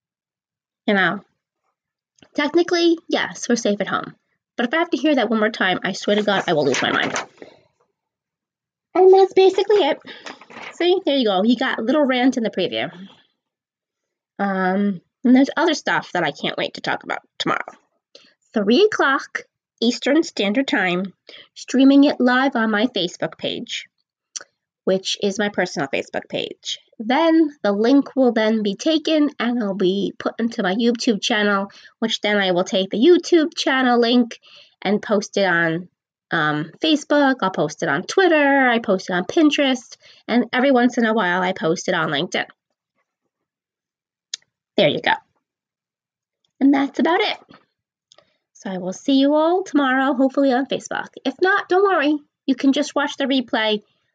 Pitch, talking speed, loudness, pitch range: 250 Hz, 170 wpm, -19 LUFS, 205-295 Hz